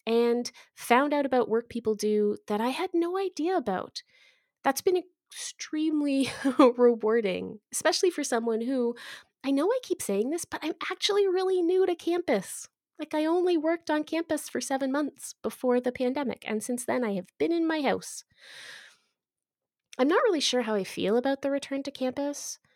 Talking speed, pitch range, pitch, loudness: 175 wpm, 240-335 Hz, 280 Hz, -28 LUFS